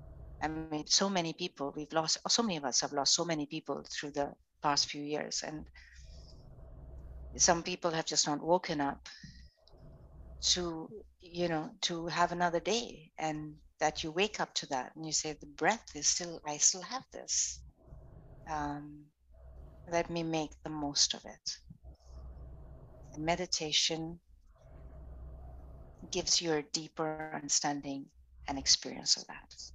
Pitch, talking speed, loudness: 150 Hz, 145 wpm, -33 LUFS